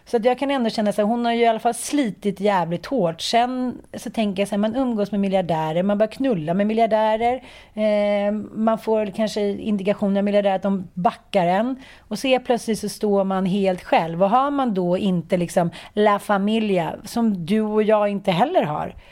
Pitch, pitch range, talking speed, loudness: 210 Hz, 195-235 Hz, 210 wpm, -21 LUFS